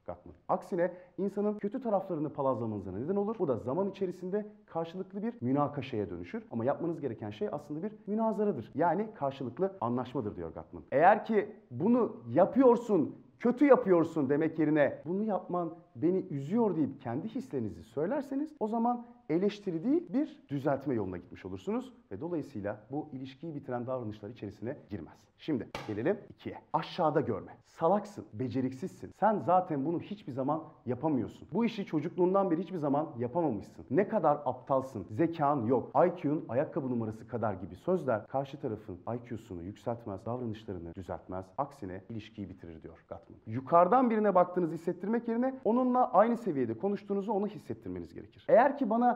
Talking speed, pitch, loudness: 145 wpm, 155 Hz, -32 LUFS